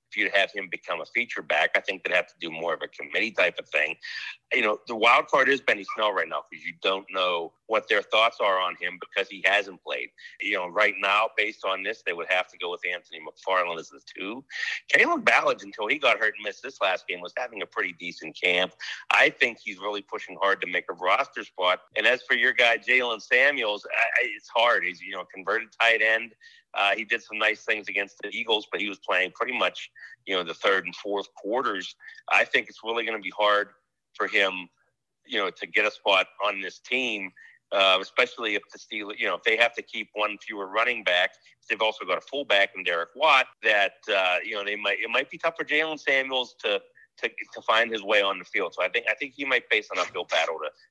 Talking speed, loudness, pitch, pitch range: 245 wpm, -25 LUFS, 110 Hz, 100-130 Hz